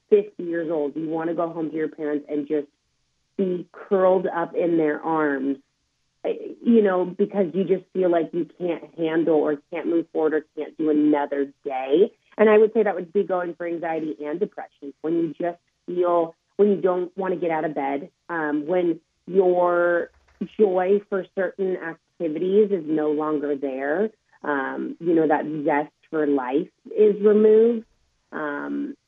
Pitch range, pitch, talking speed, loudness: 150-190 Hz, 170 Hz, 175 wpm, -23 LUFS